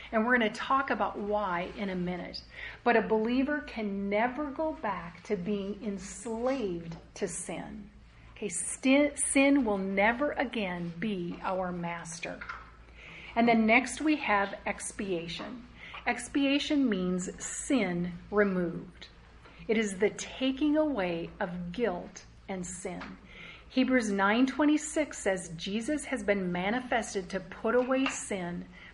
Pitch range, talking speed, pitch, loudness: 190-255 Hz, 125 wpm, 210 Hz, -30 LUFS